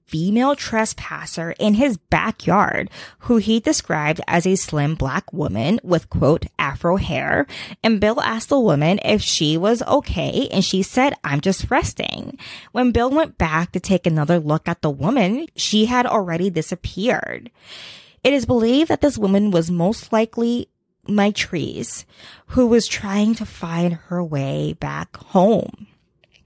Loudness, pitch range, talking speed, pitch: -19 LUFS, 170-235 Hz, 150 wpm, 200 Hz